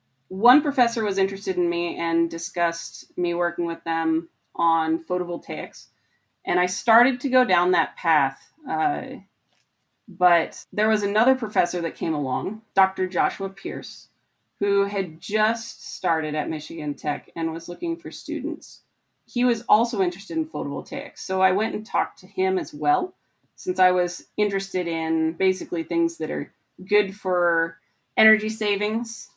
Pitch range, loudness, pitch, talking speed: 165-215 Hz, -24 LUFS, 185 Hz, 150 wpm